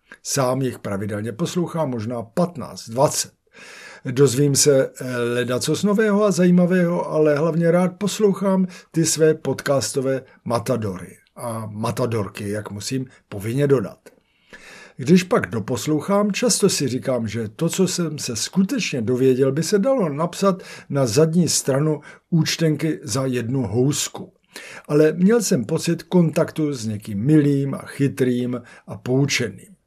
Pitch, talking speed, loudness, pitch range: 145 Hz, 130 wpm, -20 LUFS, 125-170 Hz